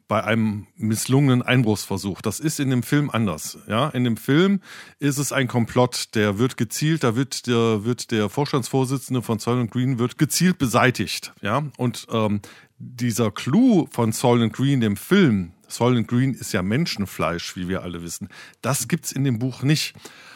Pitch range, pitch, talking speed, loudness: 110-135 Hz, 120 Hz, 175 wpm, -22 LUFS